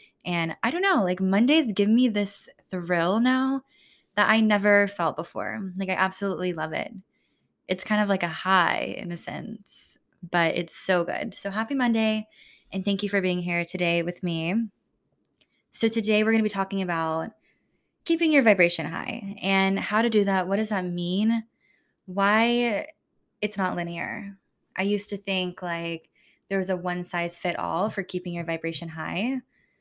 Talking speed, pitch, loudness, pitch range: 175 wpm, 195 Hz, -24 LUFS, 175-215 Hz